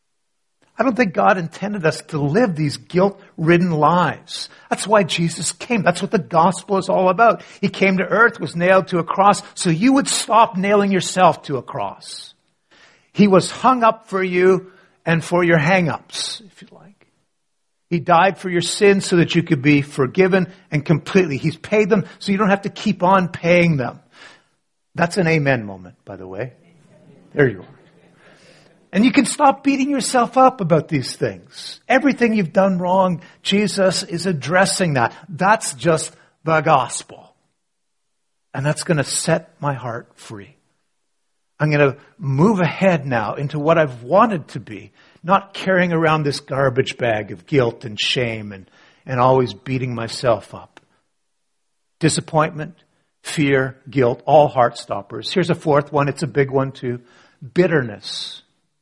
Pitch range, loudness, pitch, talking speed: 145-195 Hz, -18 LUFS, 170 Hz, 165 wpm